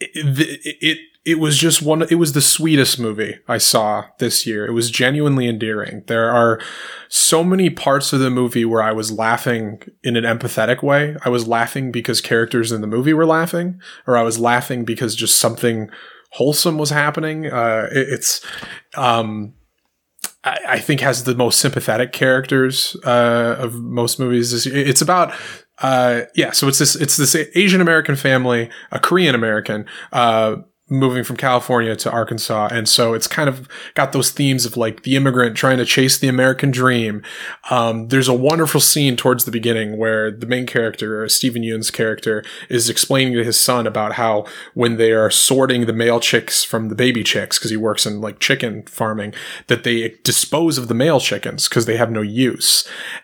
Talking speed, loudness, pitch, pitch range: 185 wpm, -16 LUFS, 120 Hz, 115-140 Hz